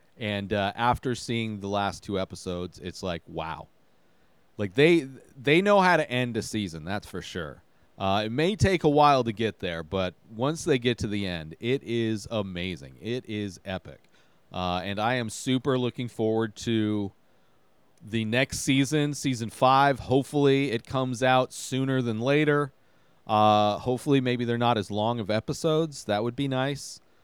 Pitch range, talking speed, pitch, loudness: 100-135 Hz, 170 wpm, 115 Hz, -26 LUFS